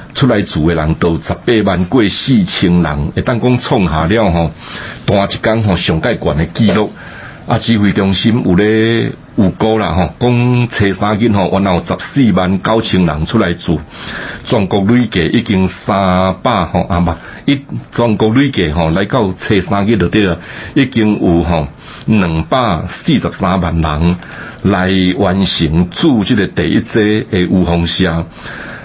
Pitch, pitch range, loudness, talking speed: 95 Hz, 85-110 Hz, -13 LUFS, 220 characters per minute